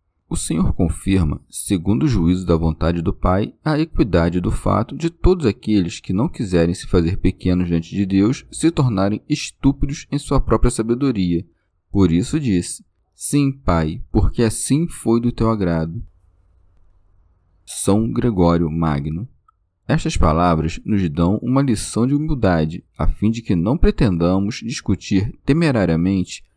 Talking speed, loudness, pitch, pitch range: 140 wpm, -19 LUFS, 95 Hz, 85-125 Hz